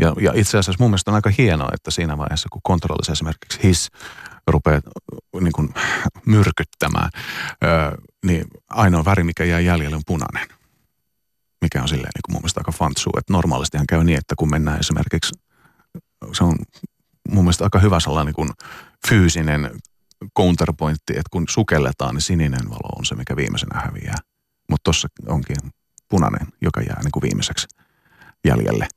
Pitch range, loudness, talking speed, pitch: 75-95 Hz, -20 LUFS, 155 wpm, 80 Hz